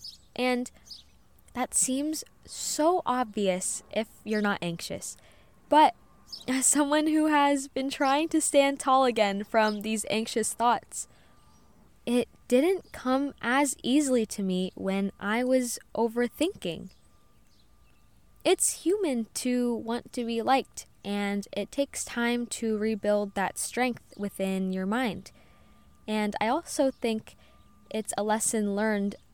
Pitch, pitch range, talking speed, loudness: 240 Hz, 210-275 Hz, 125 wpm, -28 LUFS